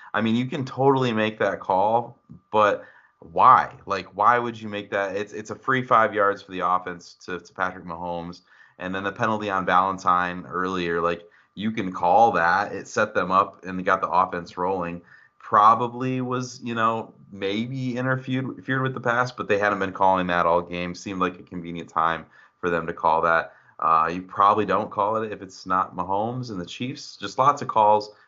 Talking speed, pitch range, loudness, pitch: 205 wpm, 90-120 Hz, -23 LUFS, 100 Hz